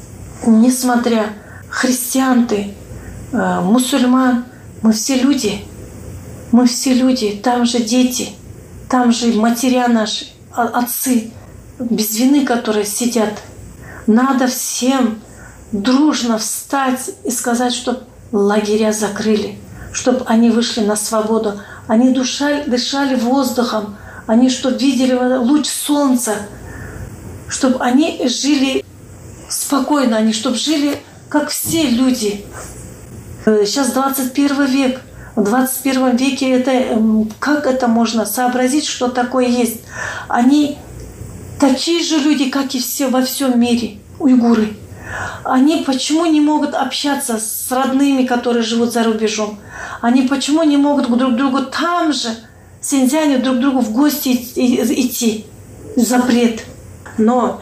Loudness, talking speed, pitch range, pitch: -15 LUFS, 115 wpm, 230-270 Hz, 250 Hz